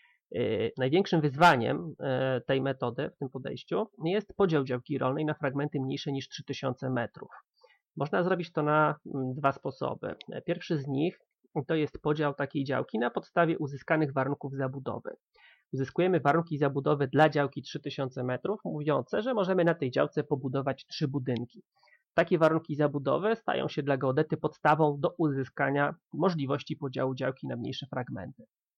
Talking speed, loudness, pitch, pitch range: 140 wpm, -30 LUFS, 145 Hz, 135-160 Hz